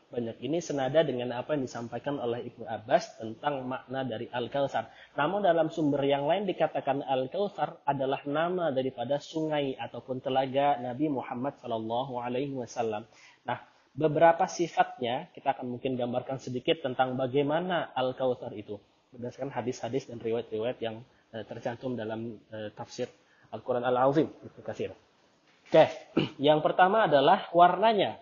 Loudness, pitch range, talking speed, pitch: -29 LUFS, 120-150 Hz, 125 wpm, 130 Hz